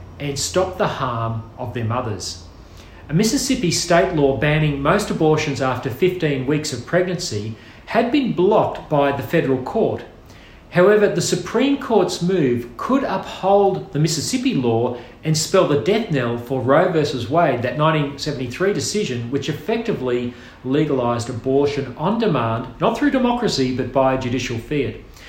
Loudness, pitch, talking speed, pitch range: -19 LUFS, 145 Hz, 145 wpm, 125-185 Hz